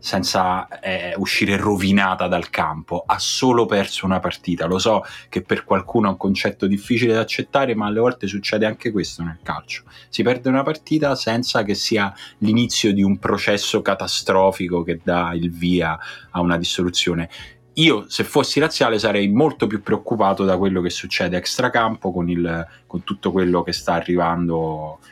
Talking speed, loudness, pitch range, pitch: 165 wpm, -20 LUFS, 90-110 Hz, 100 Hz